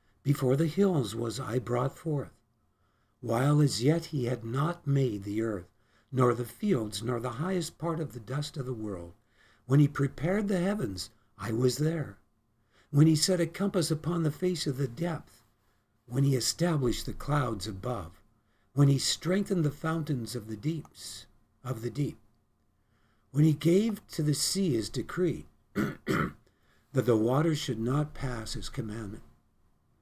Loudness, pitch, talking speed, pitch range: -30 LUFS, 130 Hz, 160 wpm, 110-155 Hz